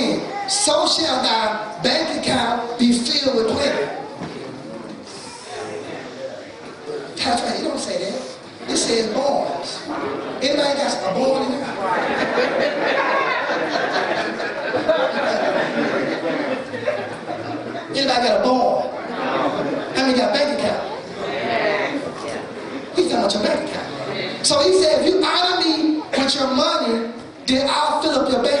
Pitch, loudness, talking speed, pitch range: 280 Hz, -20 LUFS, 130 wpm, 250-310 Hz